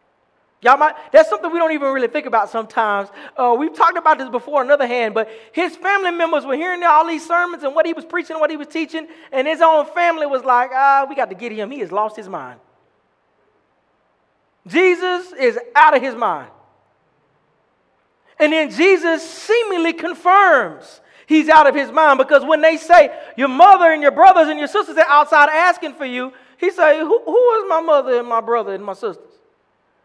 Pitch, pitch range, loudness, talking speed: 310 Hz, 270-340 Hz, -15 LUFS, 200 wpm